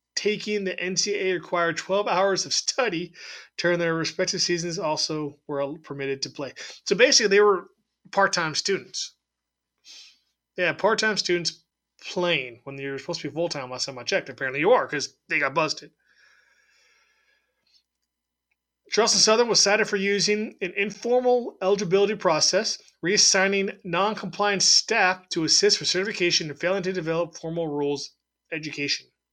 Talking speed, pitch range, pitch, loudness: 145 wpm, 155-200 Hz, 180 Hz, -23 LUFS